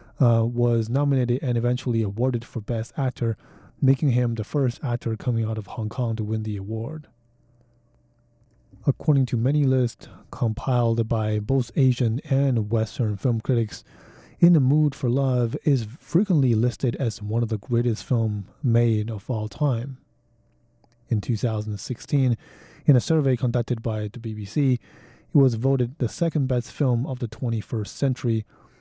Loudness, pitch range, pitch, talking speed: -24 LUFS, 115-130 Hz, 120 Hz, 150 wpm